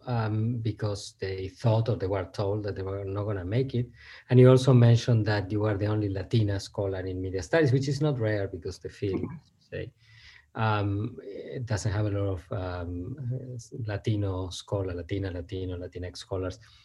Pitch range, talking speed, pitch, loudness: 95-120 Hz, 180 wpm, 105 Hz, -28 LUFS